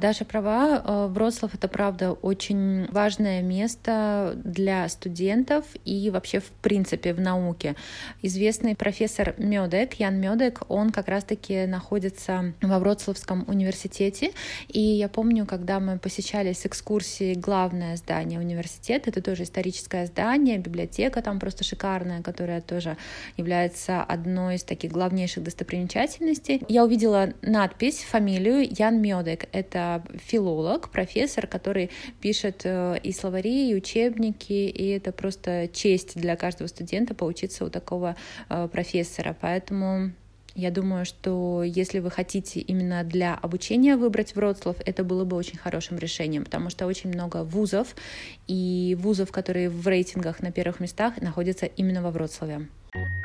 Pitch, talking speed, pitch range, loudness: 190 Hz, 130 wpm, 180-210 Hz, -26 LUFS